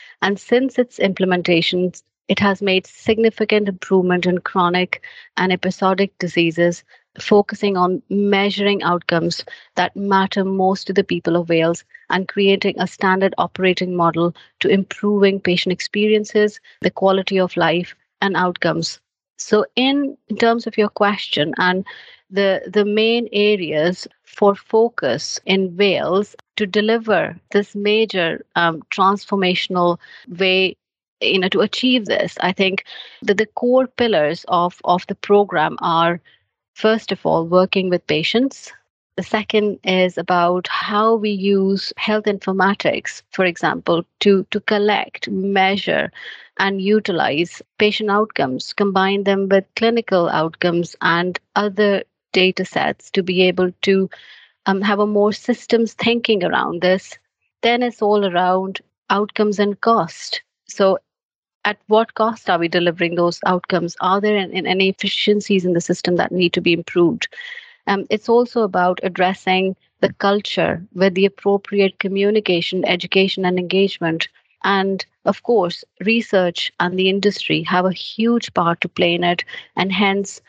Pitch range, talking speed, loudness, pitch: 180-210 Hz, 140 wpm, -18 LUFS, 195 Hz